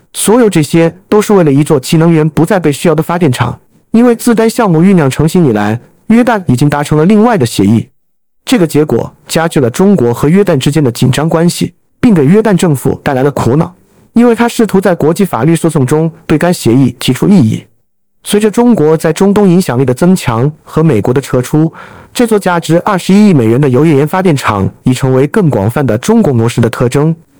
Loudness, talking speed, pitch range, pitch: -9 LUFS, 320 characters per minute, 140-195 Hz, 160 Hz